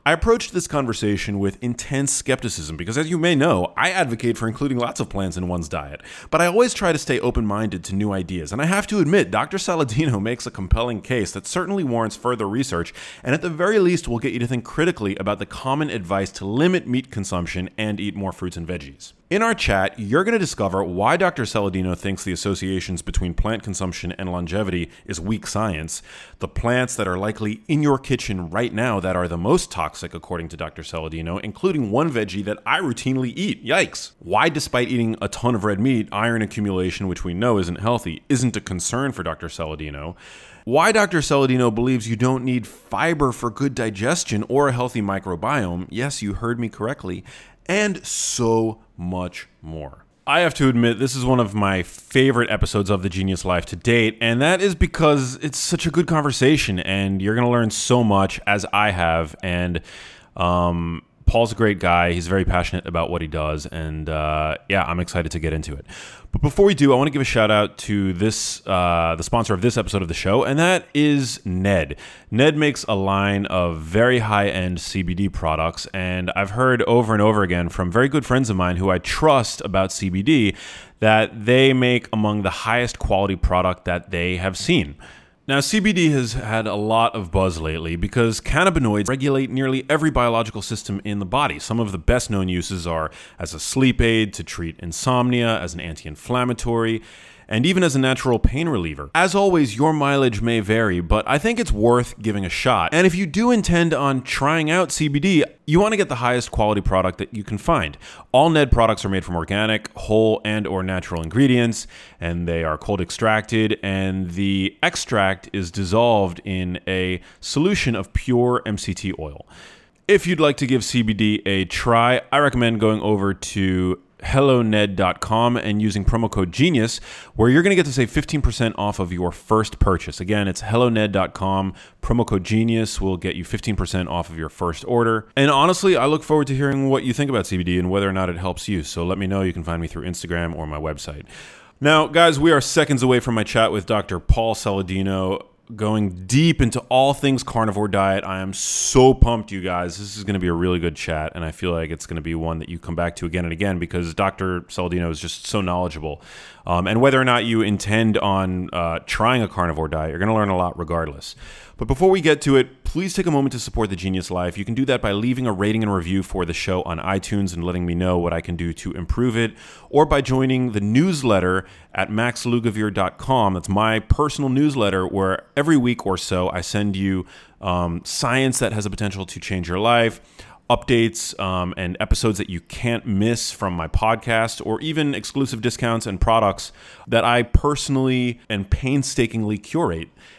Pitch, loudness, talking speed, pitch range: 105 Hz, -20 LUFS, 205 wpm, 90-125 Hz